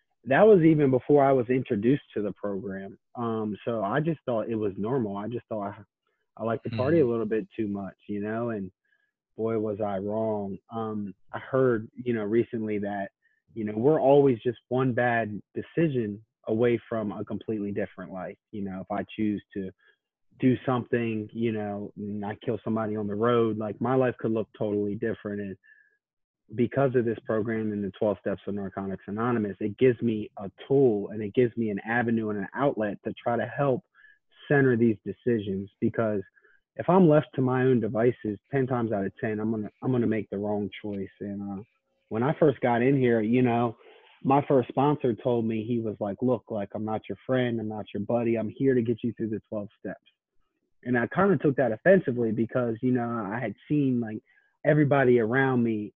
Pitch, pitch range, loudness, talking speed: 115 Hz, 105-125 Hz, -27 LUFS, 205 wpm